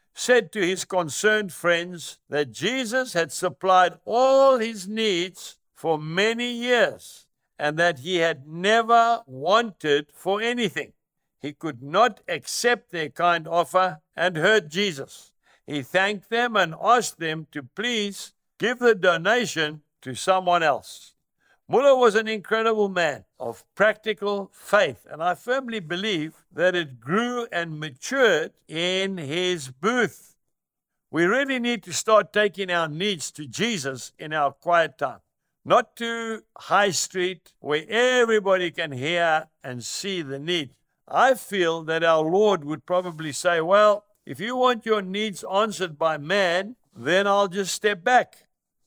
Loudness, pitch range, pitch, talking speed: -23 LUFS, 160-220 Hz, 185 Hz, 140 wpm